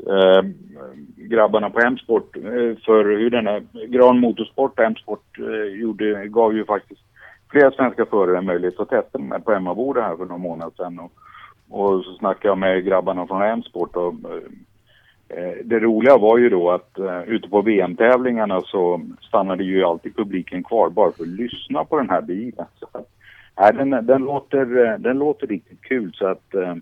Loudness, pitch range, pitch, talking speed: -19 LUFS, 95-120 Hz, 105 Hz, 170 wpm